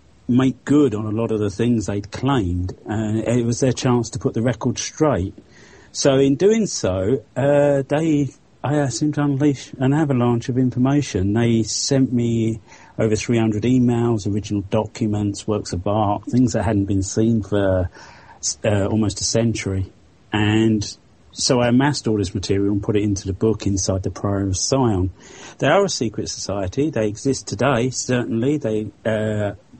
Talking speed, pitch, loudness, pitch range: 175 wpm, 110 Hz, -20 LUFS, 105-130 Hz